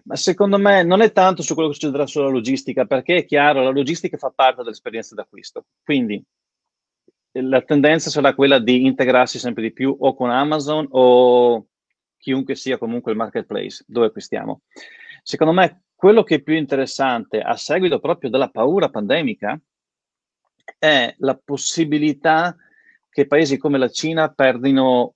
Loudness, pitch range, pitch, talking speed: -17 LUFS, 130-160 Hz, 140 Hz, 155 wpm